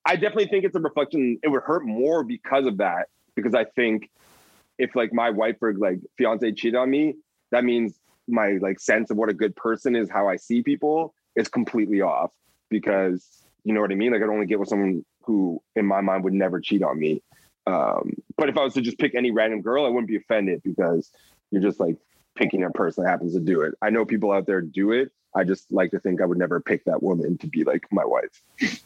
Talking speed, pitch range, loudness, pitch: 240 wpm, 100-125 Hz, -24 LUFS, 110 Hz